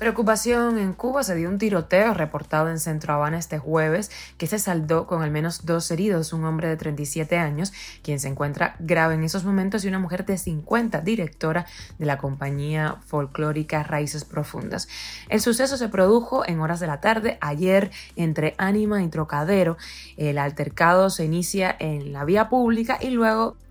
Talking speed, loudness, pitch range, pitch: 175 wpm, -23 LUFS, 155-200 Hz, 170 Hz